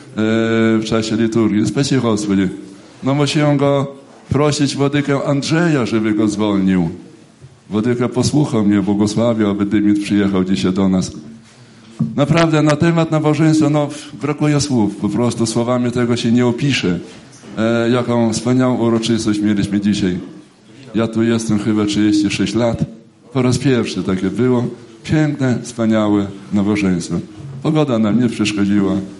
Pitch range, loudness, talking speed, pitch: 105-135 Hz, -16 LUFS, 125 wpm, 115 Hz